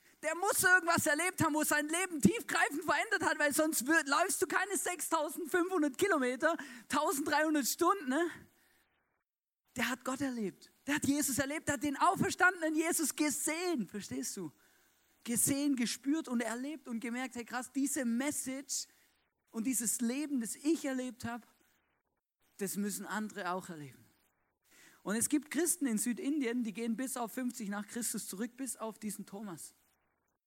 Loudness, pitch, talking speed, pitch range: -34 LUFS, 265 Hz, 155 wpm, 225-310 Hz